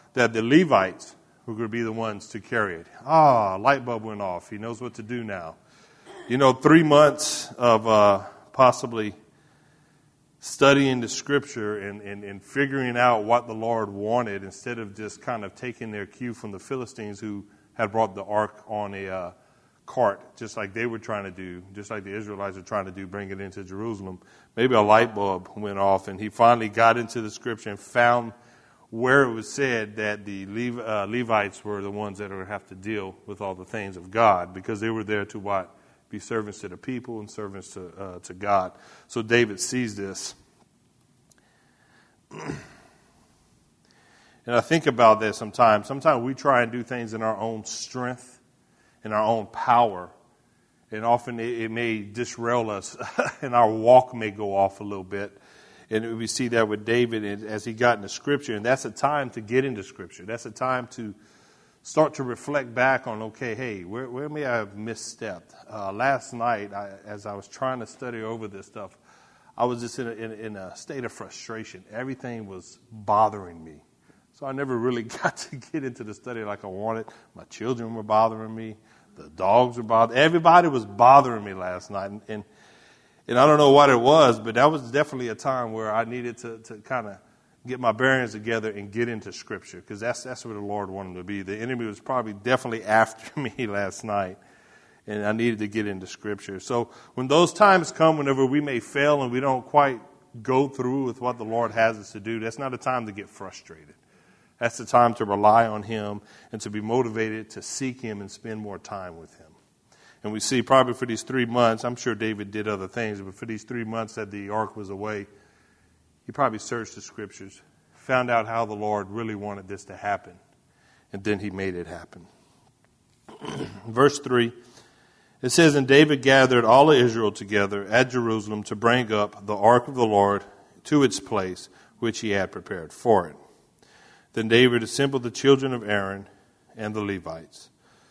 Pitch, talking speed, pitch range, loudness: 115 Hz, 200 wpm, 105-125 Hz, -24 LUFS